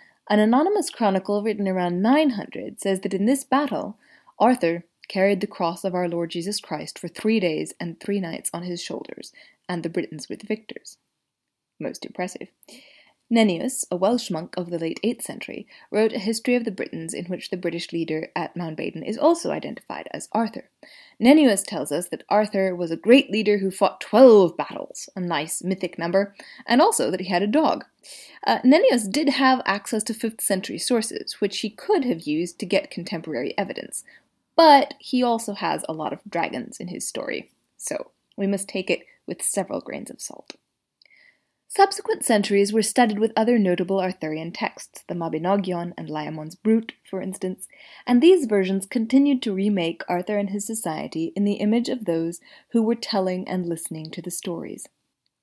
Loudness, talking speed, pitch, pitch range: -23 LUFS, 180 wpm, 200 Hz, 180-235 Hz